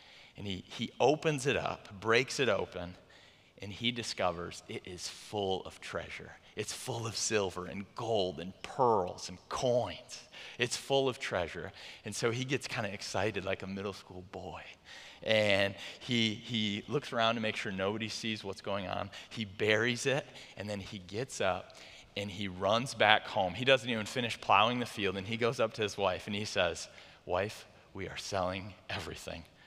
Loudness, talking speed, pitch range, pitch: -33 LUFS, 185 wpm, 95-120 Hz, 105 Hz